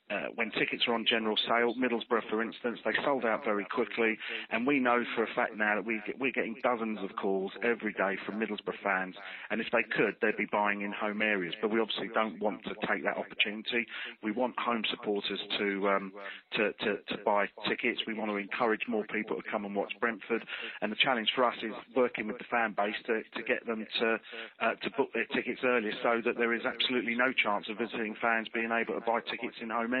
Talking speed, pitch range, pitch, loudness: 230 wpm, 105-120 Hz, 110 Hz, -31 LUFS